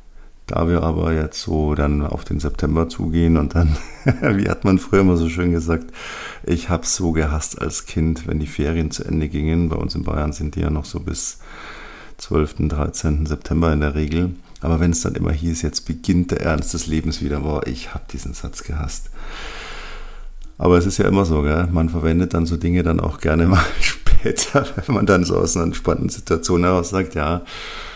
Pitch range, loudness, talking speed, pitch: 75-90 Hz, -20 LUFS, 205 wpm, 80 Hz